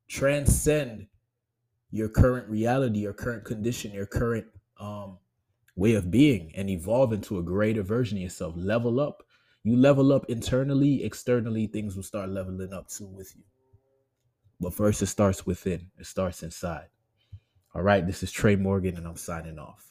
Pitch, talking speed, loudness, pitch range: 105 Hz, 165 wpm, -27 LUFS, 95-120 Hz